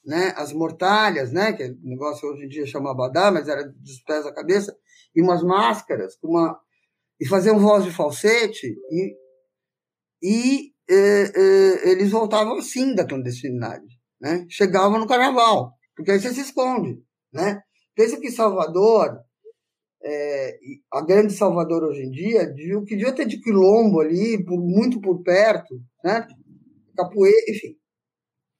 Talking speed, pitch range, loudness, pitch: 160 wpm, 155-230 Hz, -20 LUFS, 200 Hz